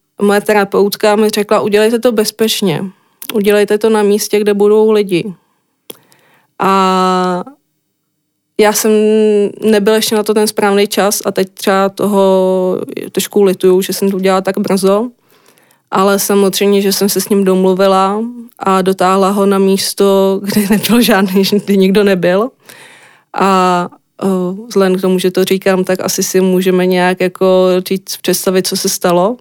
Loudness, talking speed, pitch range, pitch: -11 LUFS, 150 wpm, 190-210 Hz, 195 Hz